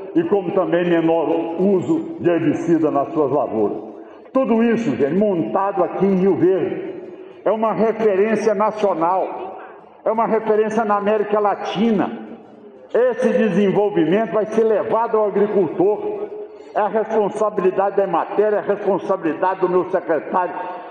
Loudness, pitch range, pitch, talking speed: -19 LUFS, 185-225 Hz, 205 Hz, 130 wpm